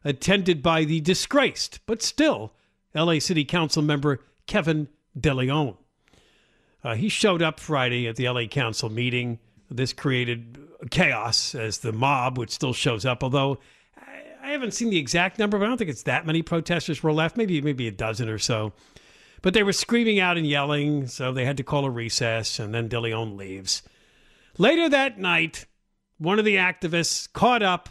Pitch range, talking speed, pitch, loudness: 120-180 Hz, 175 wpm, 150 Hz, -24 LUFS